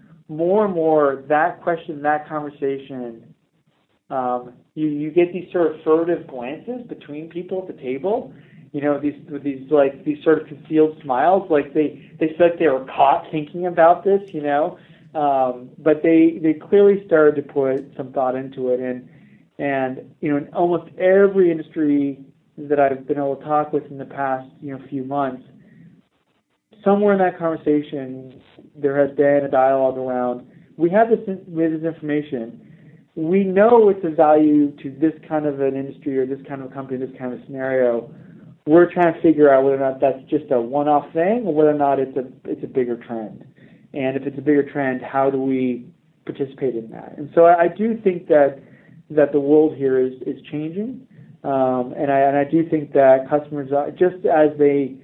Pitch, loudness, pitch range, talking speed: 150 Hz, -19 LUFS, 135-165 Hz, 190 wpm